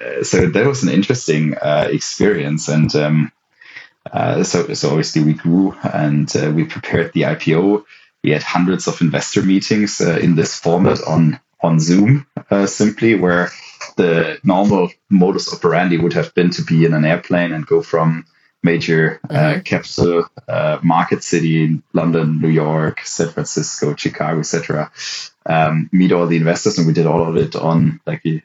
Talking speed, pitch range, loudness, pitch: 165 wpm, 80-95 Hz, -16 LUFS, 85 Hz